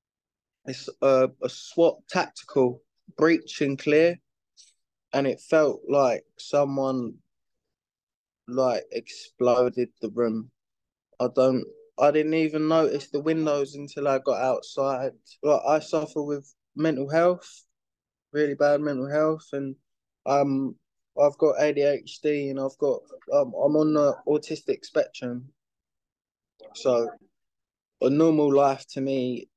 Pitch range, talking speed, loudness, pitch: 130-155 Hz, 120 wpm, -25 LUFS, 145 Hz